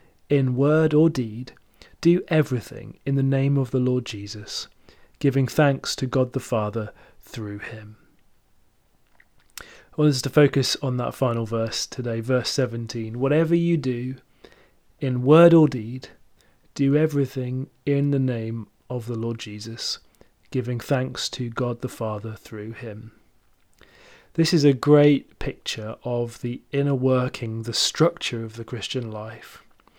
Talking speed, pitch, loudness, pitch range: 145 wpm, 125 Hz, -23 LUFS, 115-140 Hz